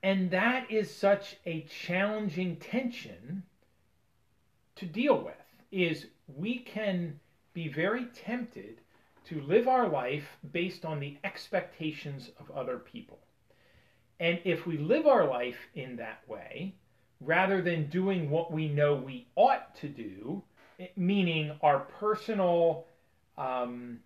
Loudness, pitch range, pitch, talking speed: -31 LUFS, 145-195 Hz, 170 Hz, 125 wpm